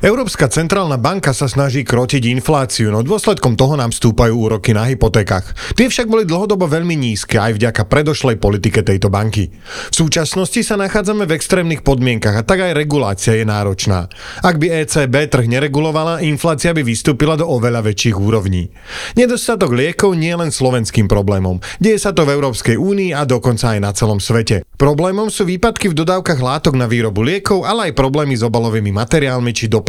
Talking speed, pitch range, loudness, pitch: 175 wpm, 115-170 Hz, -14 LUFS, 135 Hz